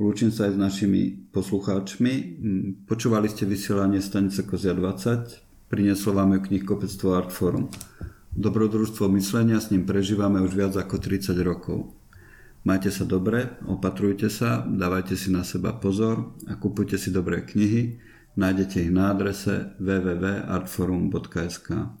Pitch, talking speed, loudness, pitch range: 100 Hz, 130 wpm, -25 LUFS, 95-105 Hz